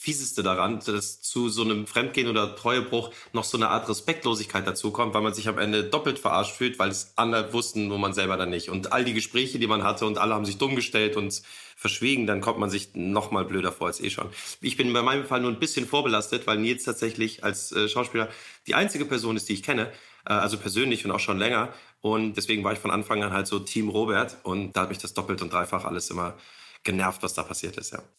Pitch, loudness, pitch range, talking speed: 110 Hz, -26 LUFS, 100-120 Hz, 240 wpm